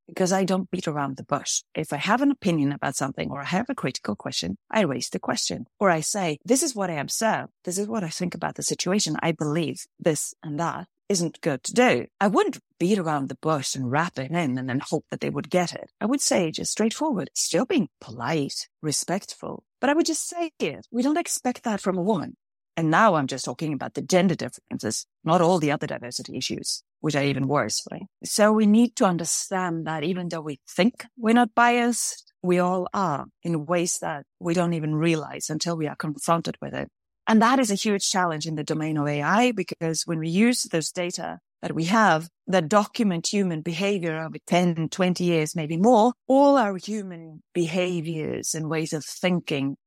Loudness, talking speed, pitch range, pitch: -24 LUFS, 215 wpm, 155-210 Hz, 175 Hz